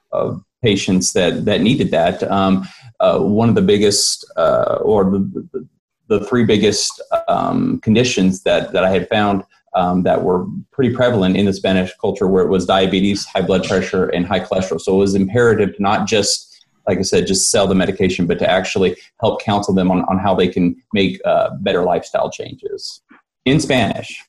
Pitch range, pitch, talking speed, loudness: 95-125 Hz, 100 Hz, 190 wpm, -16 LUFS